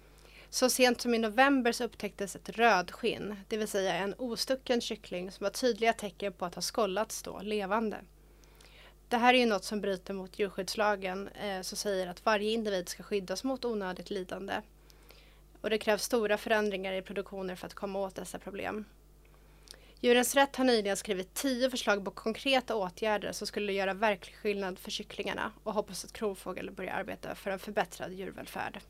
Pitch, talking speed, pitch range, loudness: 210 Hz, 175 wpm, 195-230 Hz, -32 LUFS